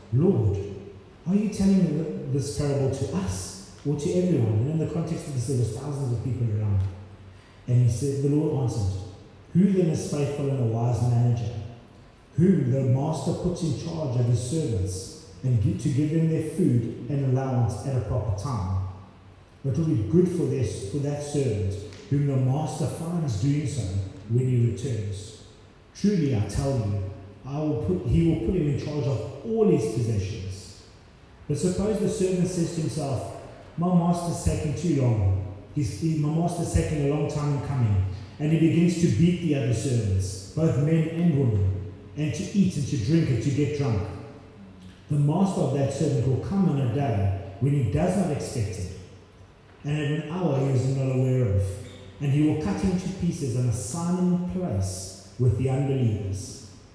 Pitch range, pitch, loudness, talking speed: 105-155 Hz, 135 Hz, -26 LUFS, 190 wpm